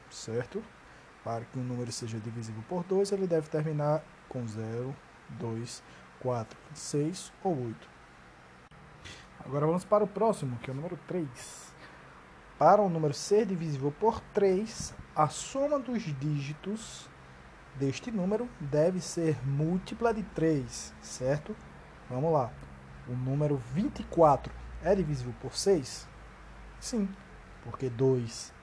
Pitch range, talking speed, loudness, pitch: 115-180 Hz, 130 wpm, -31 LUFS, 145 Hz